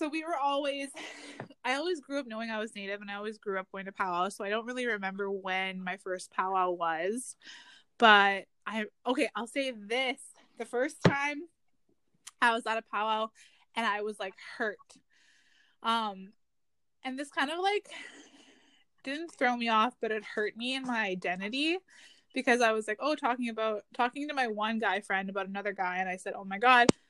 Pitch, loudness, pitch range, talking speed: 220 Hz, -31 LUFS, 200-260 Hz, 195 wpm